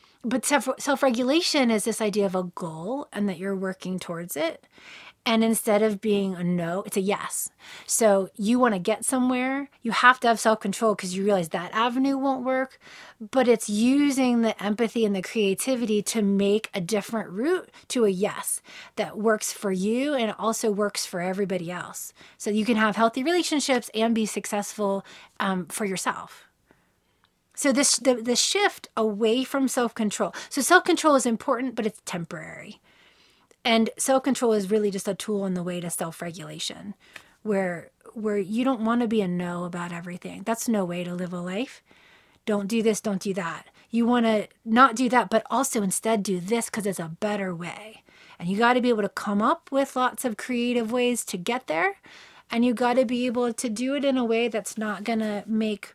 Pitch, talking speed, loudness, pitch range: 220 Hz, 200 wpm, -25 LUFS, 200-245 Hz